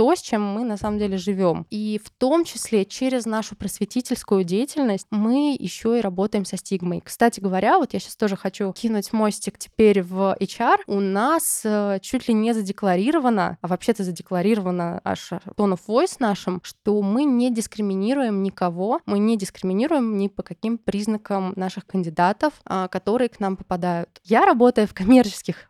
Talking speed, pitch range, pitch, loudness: 165 wpm, 190-235 Hz, 205 Hz, -22 LUFS